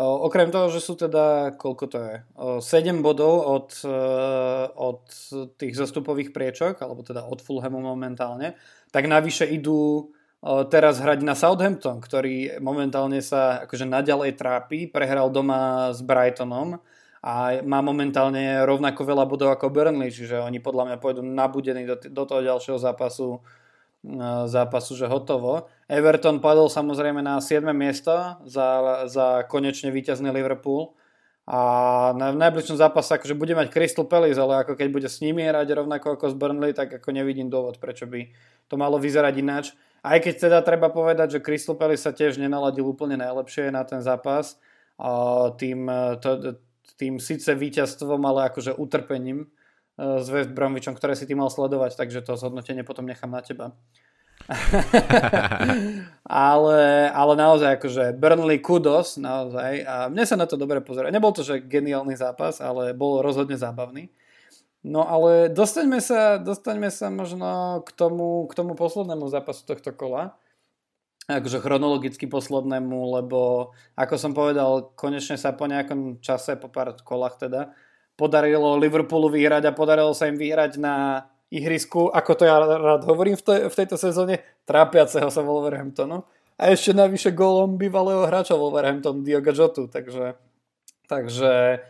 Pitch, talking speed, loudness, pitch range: 140 Hz, 145 wpm, -22 LUFS, 130-155 Hz